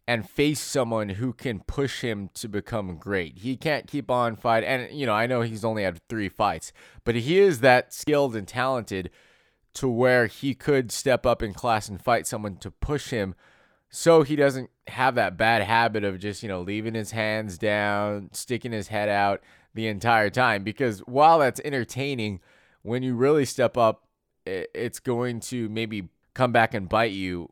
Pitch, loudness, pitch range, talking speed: 115 Hz, -25 LUFS, 105-130 Hz, 190 wpm